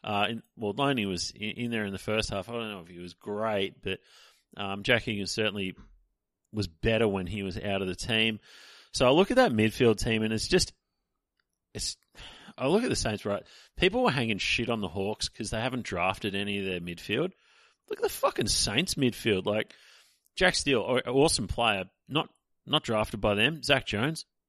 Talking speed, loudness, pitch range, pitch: 205 wpm, -28 LUFS, 100-120 Hz, 110 Hz